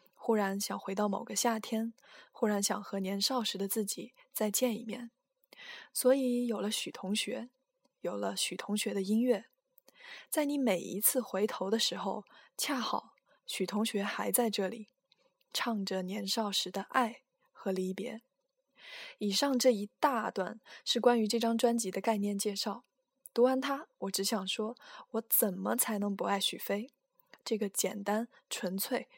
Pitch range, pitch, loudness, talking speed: 200-255 Hz, 225 Hz, -33 LUFS, 220 characters per minute